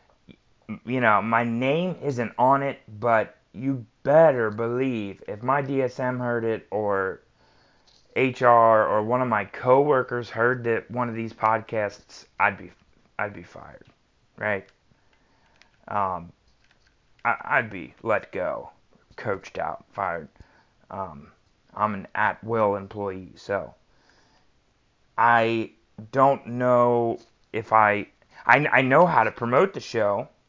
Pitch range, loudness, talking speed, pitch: 110-125 Hz, -24 LUFS, 125 wpm, 115 Hz